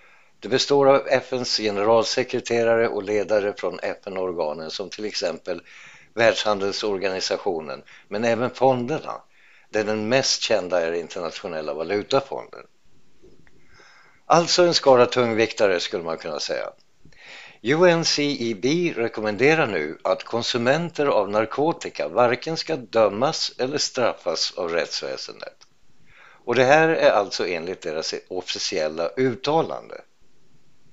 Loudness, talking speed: -22 LUFS, 105 wpm